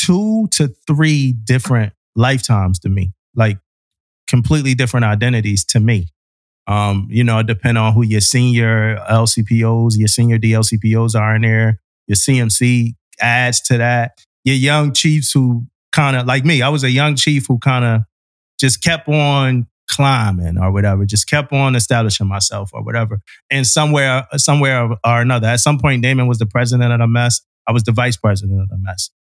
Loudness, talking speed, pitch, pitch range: -14 LUFS, 175 wpm, 120 Hz, 110-130 Hz